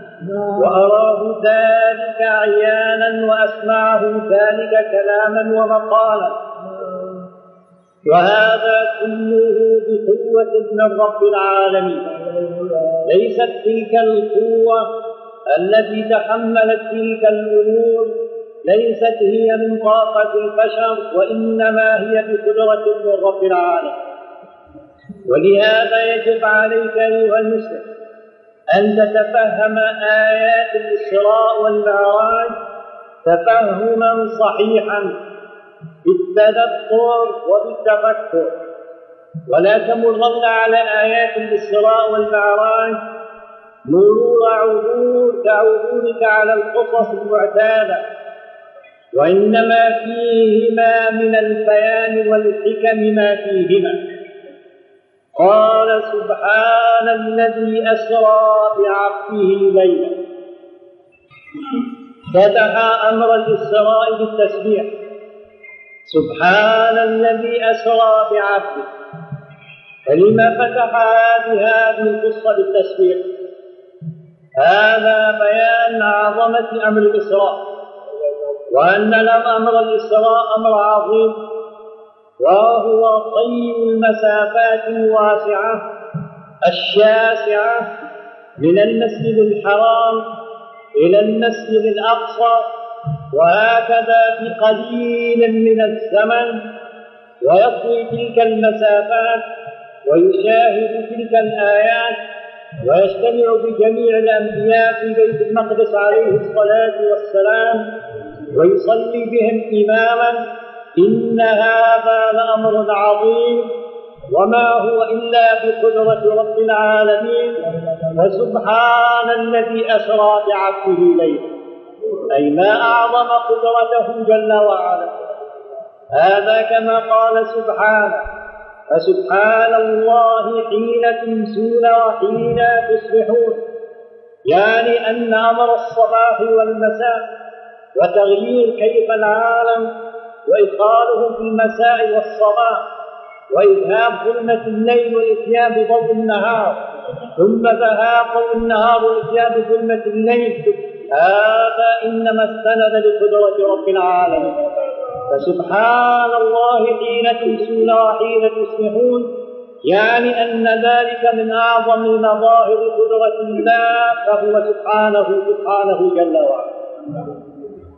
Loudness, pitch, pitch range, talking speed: -14 LUFS, 225 Hz, 215-230 Hz, 75 wpm